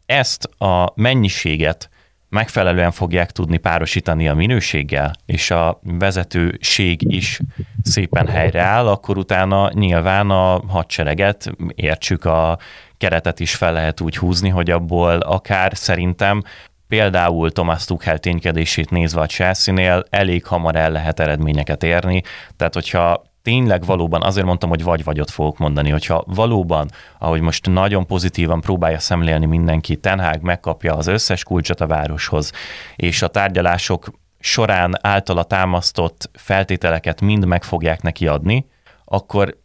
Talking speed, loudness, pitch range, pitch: 130 wpm, -17 LUFS, 80-95 Hz, 90 Hz